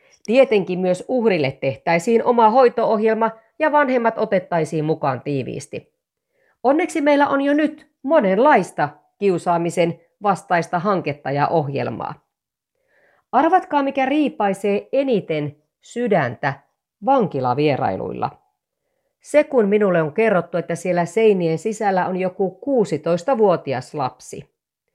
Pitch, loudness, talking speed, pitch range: 200 Hz, -19 LUFS, 100 wpm, 165-265 Hz